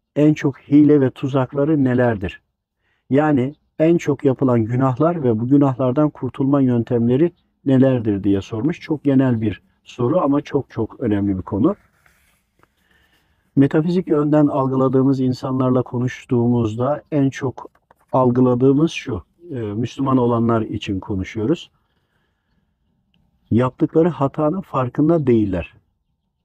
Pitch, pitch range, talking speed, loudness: 130 Hz, 120-145 Hz, 105 wpm, -18 LUFS